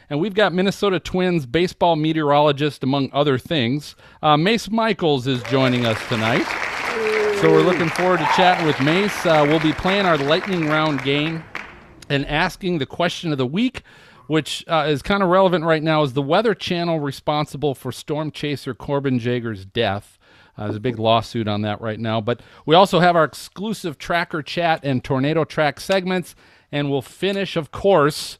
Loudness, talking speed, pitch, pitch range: -20 LUFS, 180 wpm, 155 Hz, 135-180 Hz